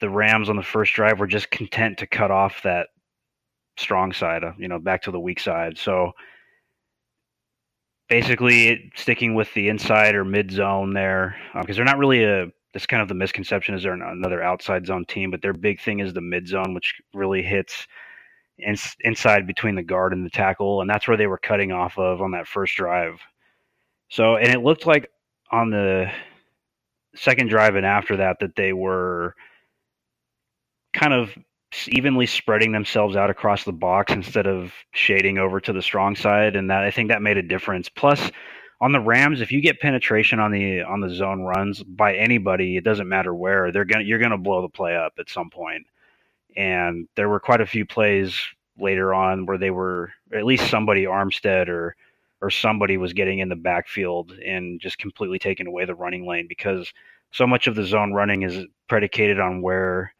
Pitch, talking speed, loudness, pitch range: 100 Hz, 195 wpm, -21 LUFS, 95-110 Hz